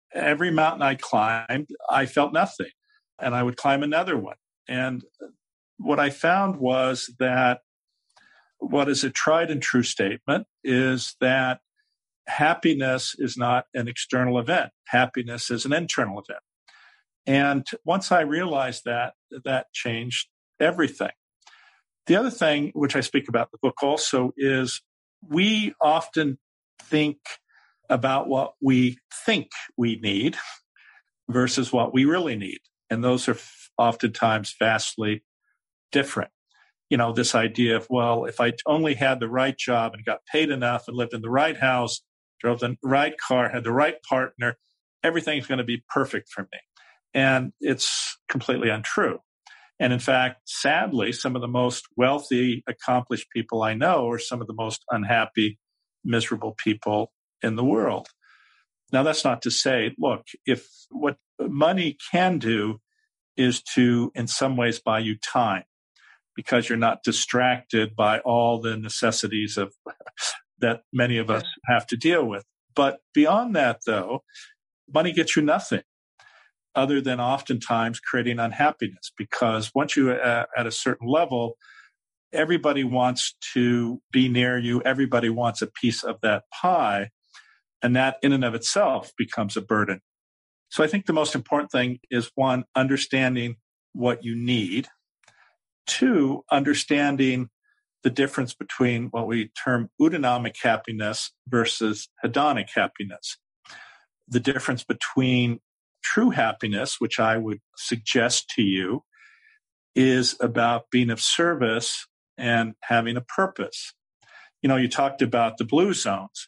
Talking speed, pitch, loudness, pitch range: 140 wpm, 125 Hz, -24 LUFS, 120-140 Hz